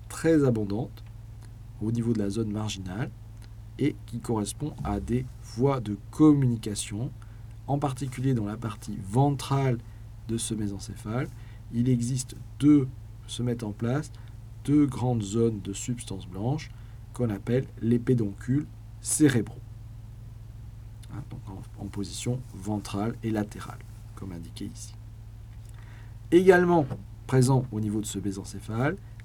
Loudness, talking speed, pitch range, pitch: -28 LUFS, 125 wpm, 110-125 Hz, 110 Hz